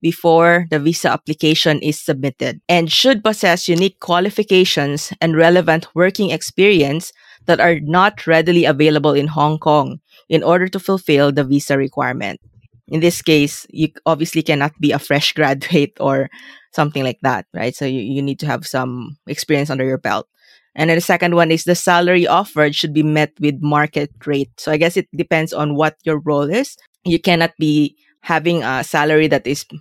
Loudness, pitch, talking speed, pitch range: -16 LUFS, 155 Hz, 180 wpm, 145-170 Hz